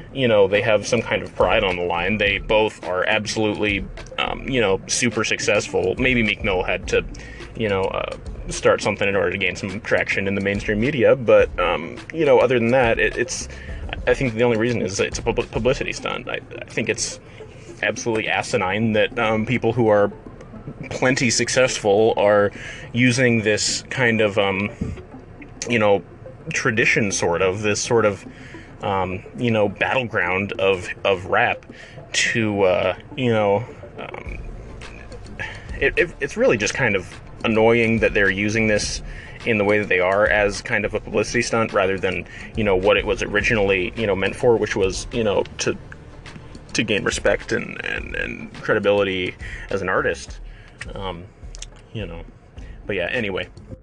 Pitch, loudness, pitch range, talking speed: 110 Hz, -20 LUFS, 100-125 Hz, 175 wpm